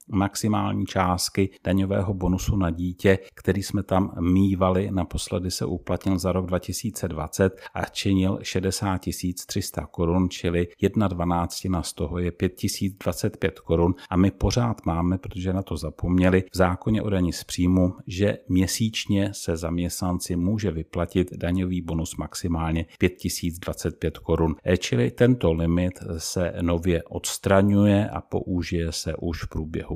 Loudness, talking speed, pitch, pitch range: -25 LUFS, 130 wpm, 90 Hz, 85-100 Hz